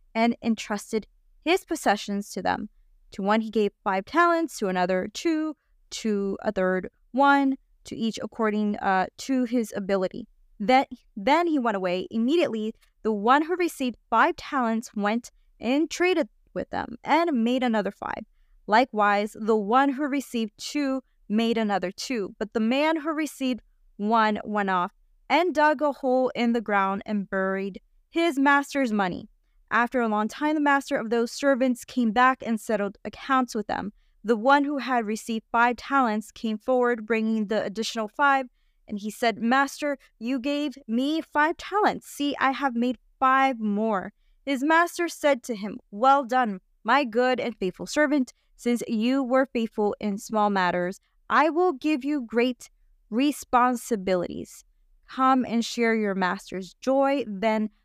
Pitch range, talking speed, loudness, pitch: 215-275 Hz, 160 wpm, -25 LUFS, 240 Hz